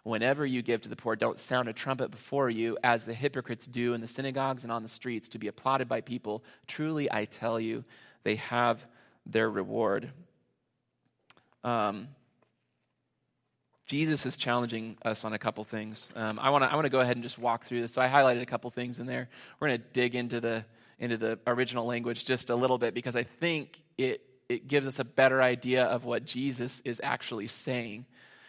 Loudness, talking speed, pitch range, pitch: -31 LUFS, 200 wpm, 115-130 Hz, 120 Hz